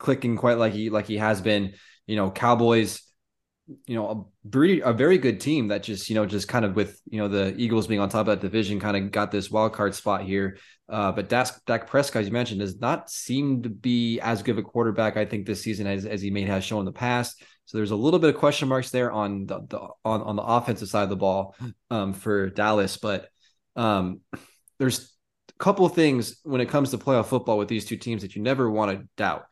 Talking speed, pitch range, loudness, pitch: 245 wpm, 105-120 Hz, -25 LUFS, 110 Hz